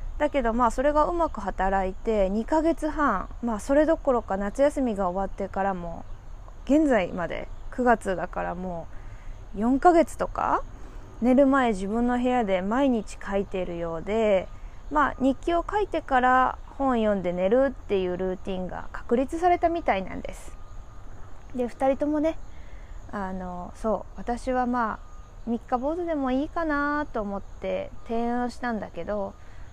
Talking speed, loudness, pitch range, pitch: 285 characters per minute, -26 LUFS, 195-275 Hz, 235 Hz